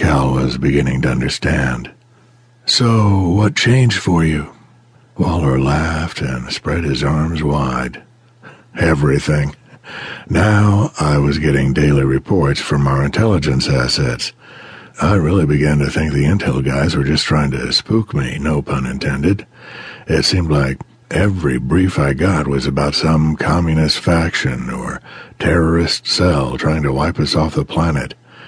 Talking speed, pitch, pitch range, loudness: 135 wpm, 75 Hz, 70-95 Hz, -16 LUFS